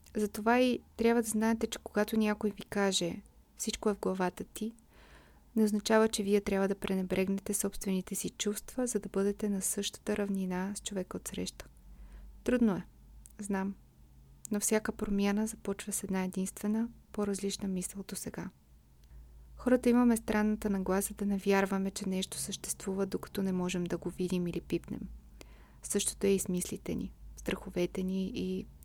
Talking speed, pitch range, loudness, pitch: 160 wpm, 185-215 Hz, -33 LUFS, 200 Hz